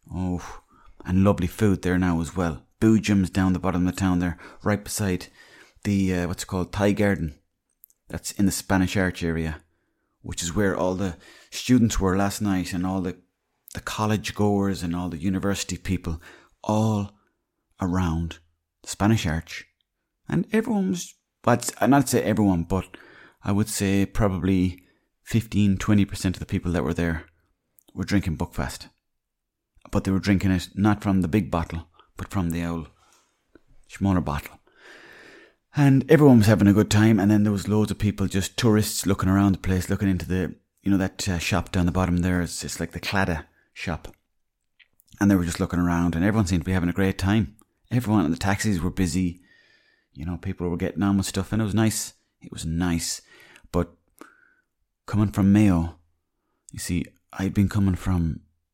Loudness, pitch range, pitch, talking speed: -24 LUFS, 85-100 Hz, 95 Hz, 185 wpm